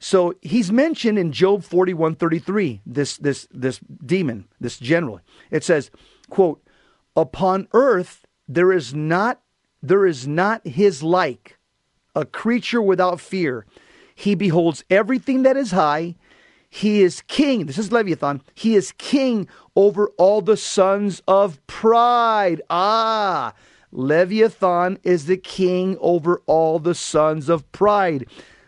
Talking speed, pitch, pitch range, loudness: 130 wpm, 185 Hz, 165-205 Hz, -19 LUFS